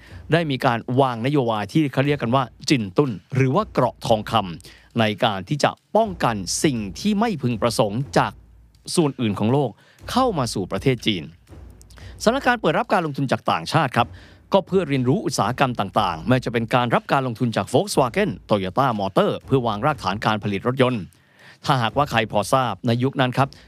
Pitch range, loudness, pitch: 110-145 Hz, -21 LUFS, 125 Hz